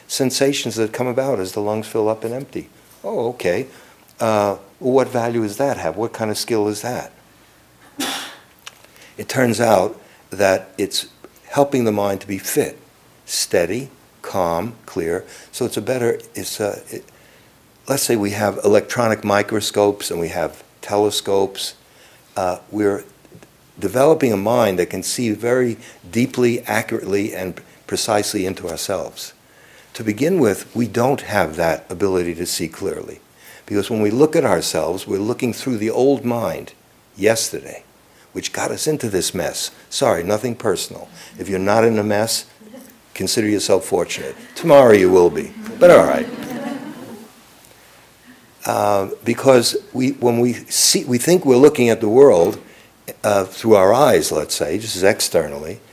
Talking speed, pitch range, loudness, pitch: 150 wpm, 105-130 Hz, -18 LUFS, 115 Hz